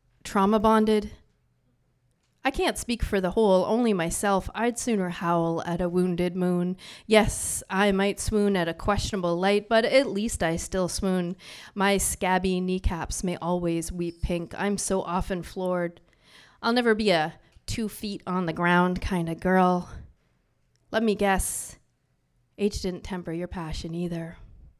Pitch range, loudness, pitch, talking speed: 175-205 Hz, -26 LUFS, 185 Hz, 150 wpm